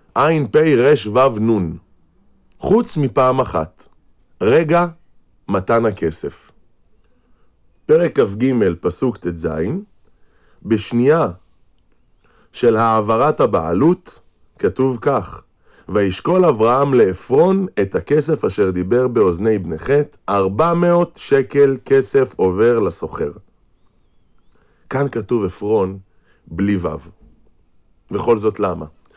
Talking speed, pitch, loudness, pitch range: 90 wpm, 115 Hz, -17 LUFS, 90-140 Hz